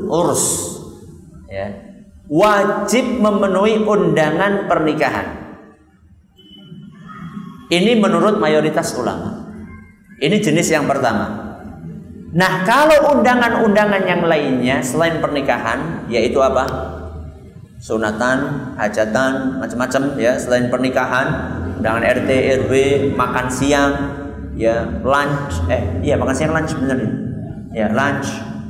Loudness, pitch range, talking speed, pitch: -16 LUFS, 125-185 Hz, 90 wpm, 140 Hz